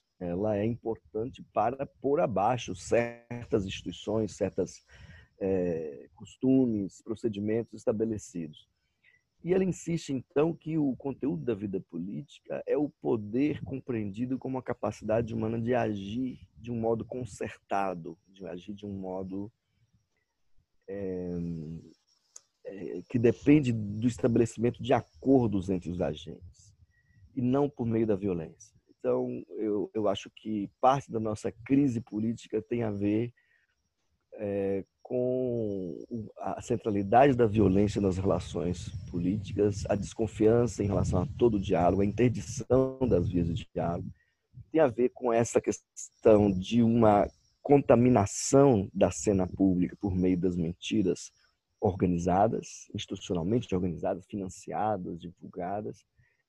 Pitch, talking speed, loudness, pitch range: 110 Hz, 120 wpm, -29 LUFS, 95-120 Hz